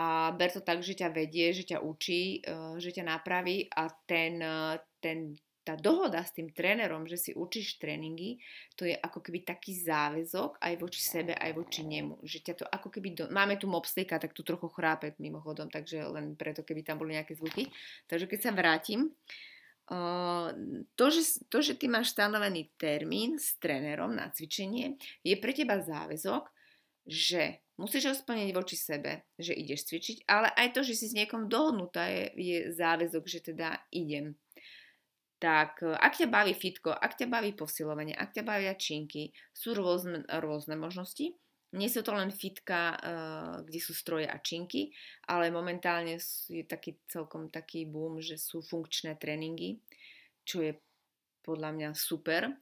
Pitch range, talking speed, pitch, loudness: 160-200 Hz, 165 wpm, 170 Hz, -34 LUFS